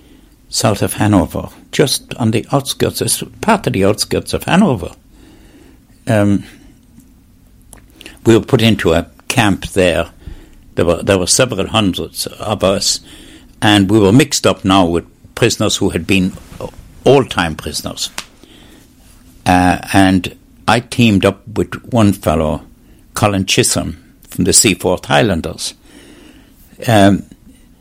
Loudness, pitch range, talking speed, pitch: -14 LUFS, 90-110 Hz, 125 wpm, 100 Hz